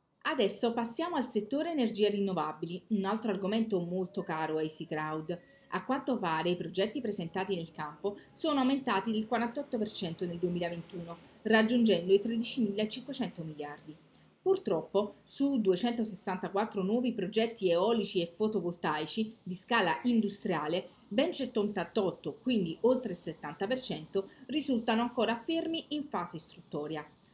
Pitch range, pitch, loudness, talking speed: 175-235 Hz, 205 Hz, -33 LUFS, 120 wpm